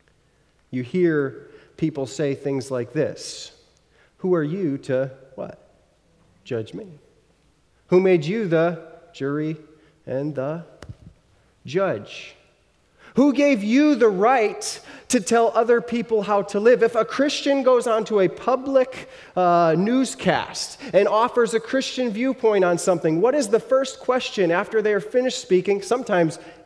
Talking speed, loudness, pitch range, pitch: 135 wpm, -21 LUFS, 165-245 Hz, 205 Hz